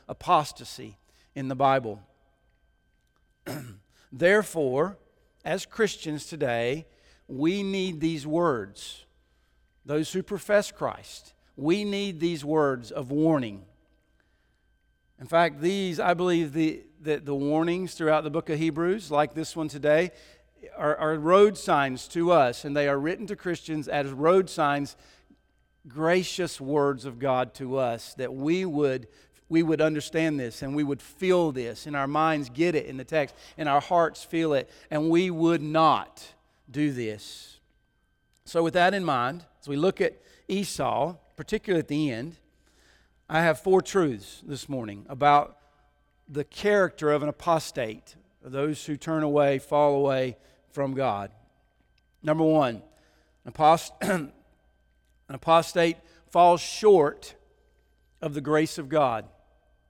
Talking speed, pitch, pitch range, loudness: 140 wpm, 150 Hz, 135-170 Hz, -26 LUFS